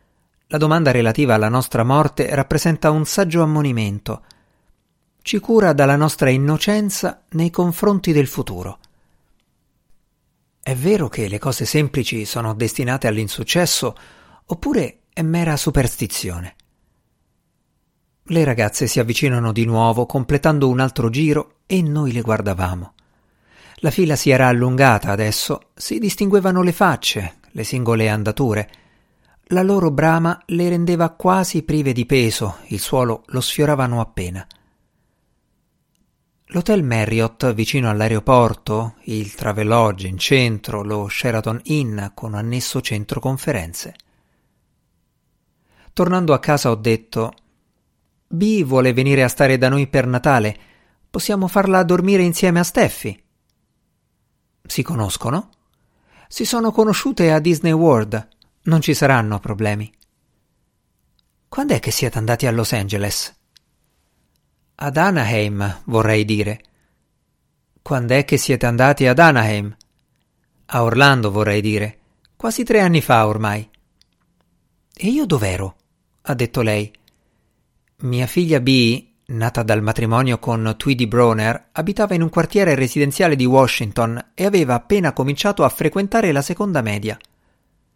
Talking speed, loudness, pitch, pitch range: 120 wpm, -18 LUFS, 130 Hz, 110-160 Hz